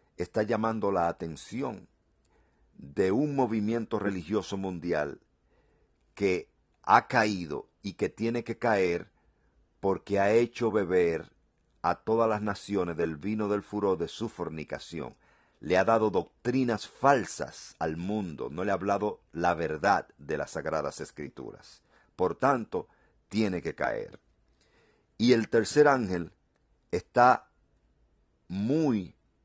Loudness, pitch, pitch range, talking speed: -29 LUFS, 100 Hz, 85-115 Hz, 120 wpm